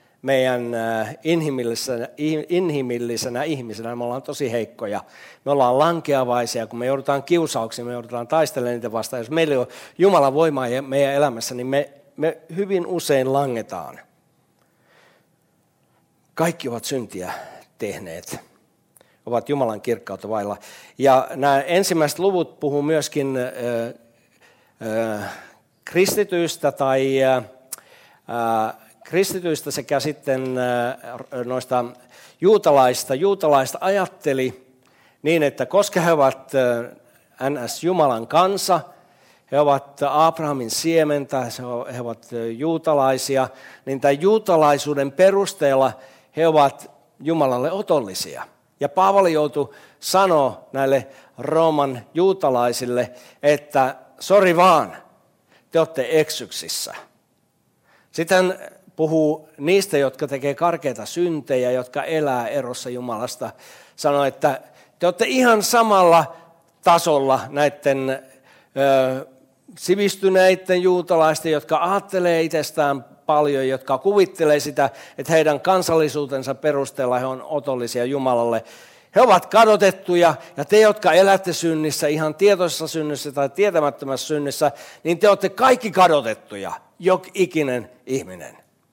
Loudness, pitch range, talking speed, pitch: -20 LUFS, 130-165 Hz, 105 wpm, 145 Hz